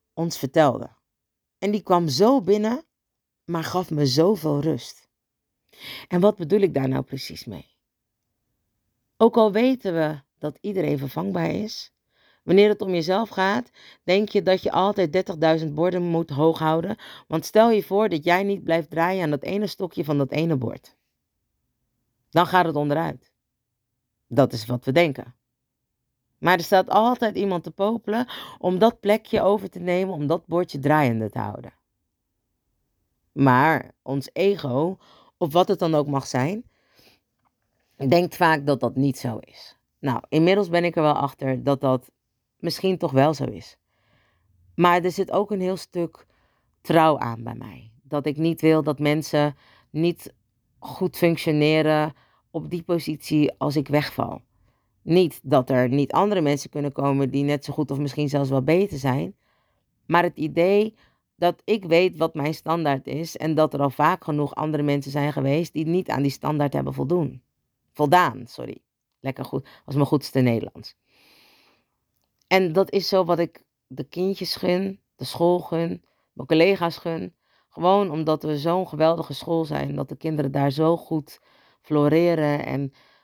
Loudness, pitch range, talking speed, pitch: -22 LUFS, 135-180 Hz, 165 wpm, 155 Hz